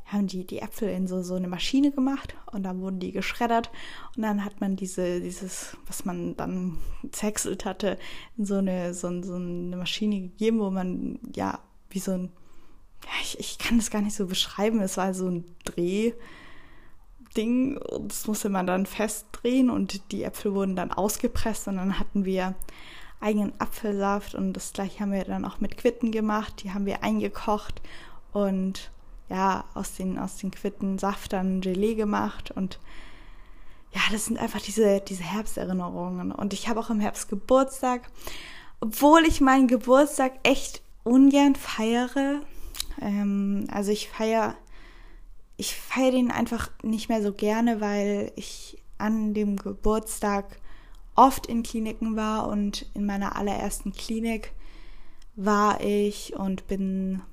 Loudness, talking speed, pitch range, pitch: -27 LUFS, 155 wpm, 190-225 Hz, 205 Hz